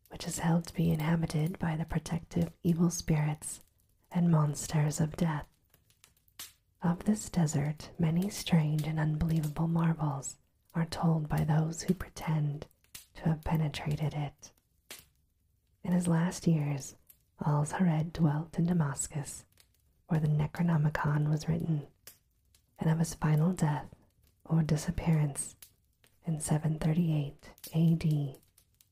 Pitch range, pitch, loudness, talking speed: 150-165 Hz, 155 Hz, -32 LUFS, 120 wpm